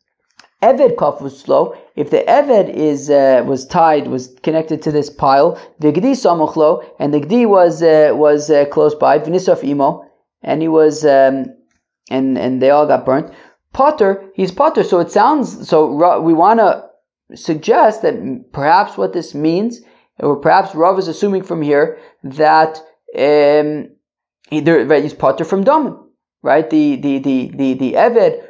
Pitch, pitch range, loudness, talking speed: 160 Hz, 145-205 Hz, -13 LUFS, 165 wpm